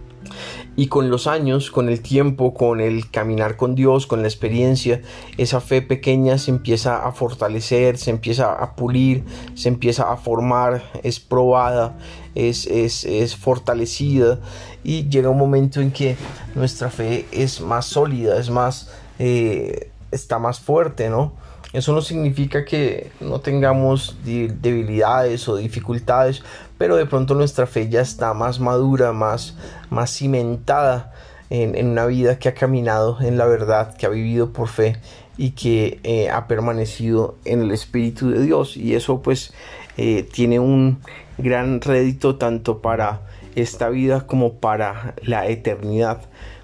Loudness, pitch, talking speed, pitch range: -19 LUFS, 120 Hz, 150 wpm, 115-130 Hz